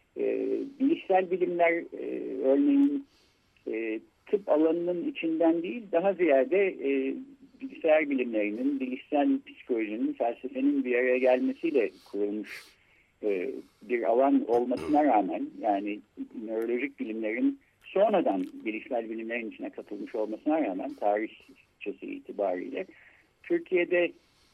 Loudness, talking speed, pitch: -28 LUFS, 100 wpm, 175 Hz